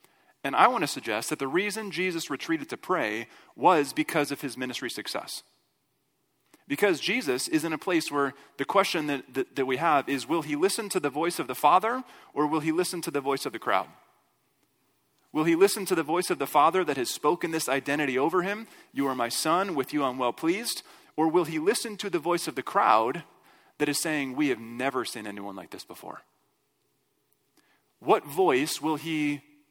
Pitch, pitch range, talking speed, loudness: 150 Hz, 135-175 Hz, 205 wpm, -27 LUFS